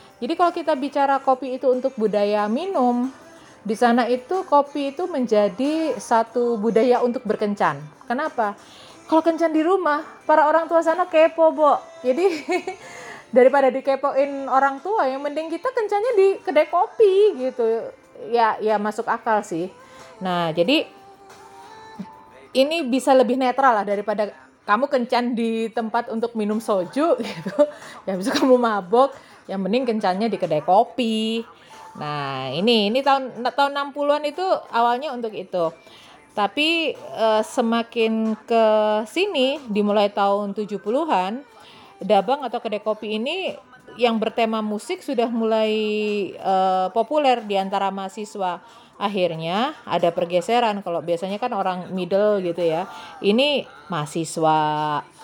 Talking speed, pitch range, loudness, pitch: 130 wpm, 205-280 Hz, -21 LUFS, 235 Hz